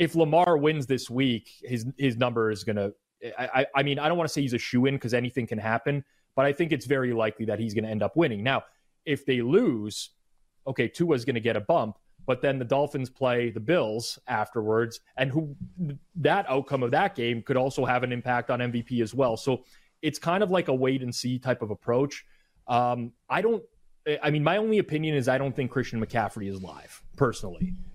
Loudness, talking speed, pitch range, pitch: -27 LUFS, 215 wpm, 120-145 Hz, 130 Hz